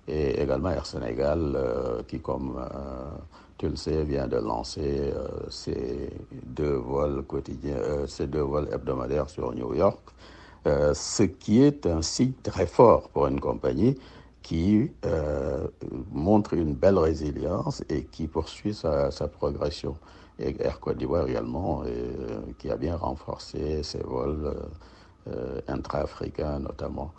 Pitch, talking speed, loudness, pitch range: 75 Hz, 145 wpm, -28 LUFS, 70-90 Hz